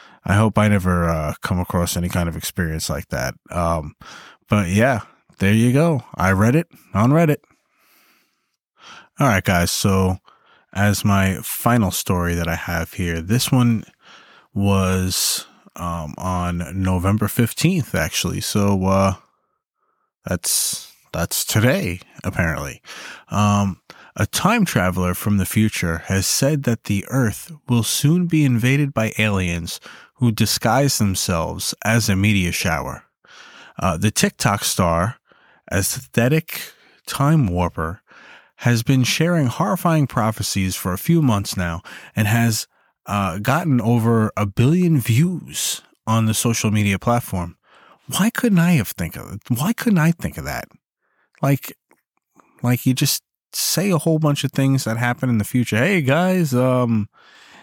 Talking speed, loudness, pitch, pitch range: 140 wpm, -19 LUFS, 110 Hz, 95-135 Hz